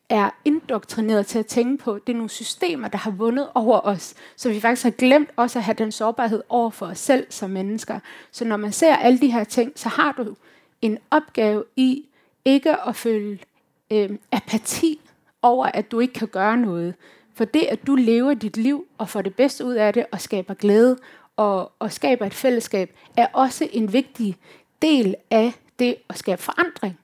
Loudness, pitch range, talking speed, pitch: -21 LUFS, 210-255 Hz, 200 wpm, 230 Hz